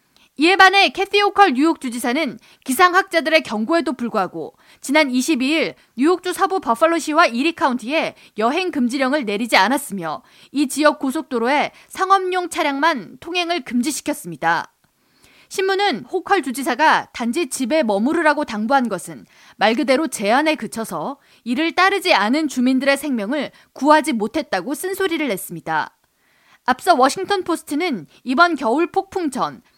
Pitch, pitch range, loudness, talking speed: 300 Hz, 255-345 Hz, -18 LUFS, 325 characters per minute